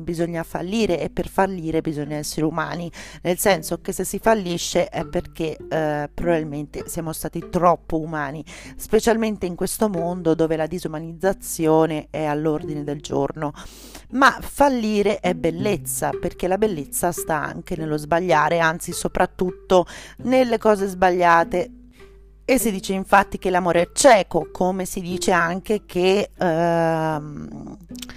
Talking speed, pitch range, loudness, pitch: 135 wpm, 155-190 Hz, -21 LUFS, 170 Hz